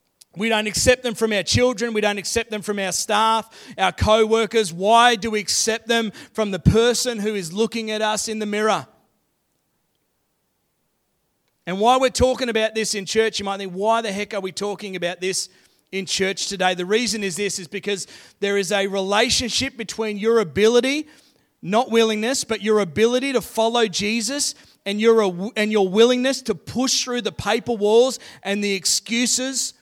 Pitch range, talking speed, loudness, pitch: 200-235 Hz, 180 wpm, -20 LUFS, 220 Hz